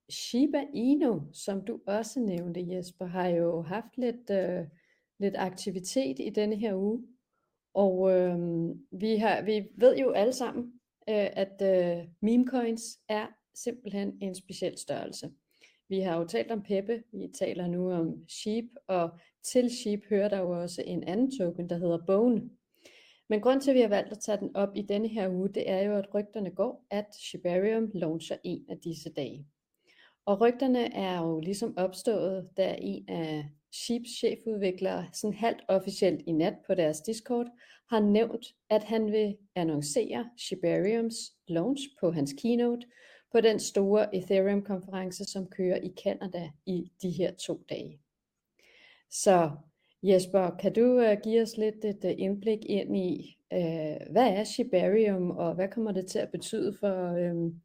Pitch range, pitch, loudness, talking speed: 180-225 Hz, 200 Hz, -30 LUFS, 160 wpm